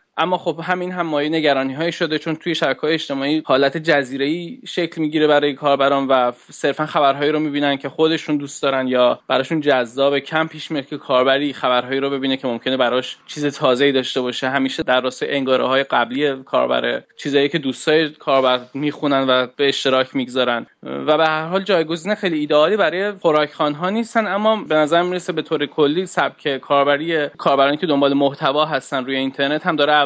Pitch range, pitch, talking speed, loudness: 135-160 Hz, 145 Hz, 175 wpm, -18 LUFS